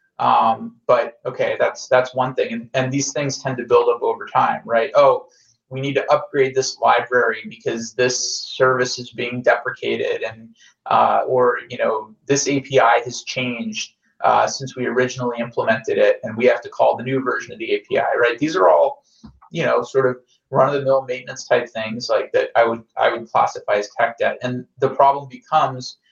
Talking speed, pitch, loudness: 190 wpm, 130 Hz, -19 LUFS